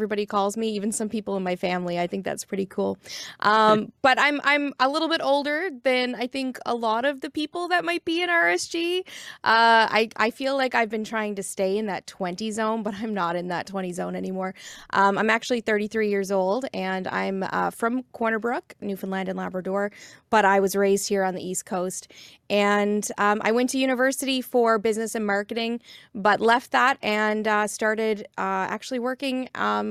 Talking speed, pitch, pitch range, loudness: 205 wpm, 215 Hz, 195-250 Hz, -24 LUFS